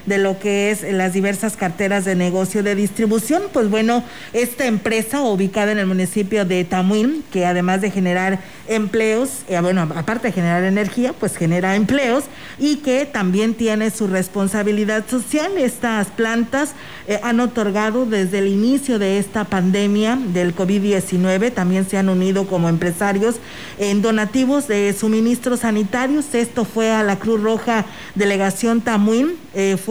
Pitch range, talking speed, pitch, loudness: 195-235 Hz, 155 wpm, 210 Hz, -18 LUFS